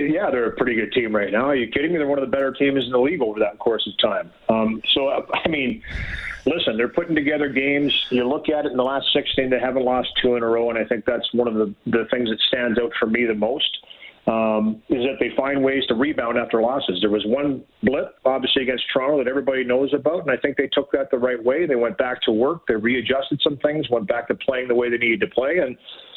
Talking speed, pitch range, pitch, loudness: 265 wpm, 120-140 Hz, 130 Hz, -21 LUFS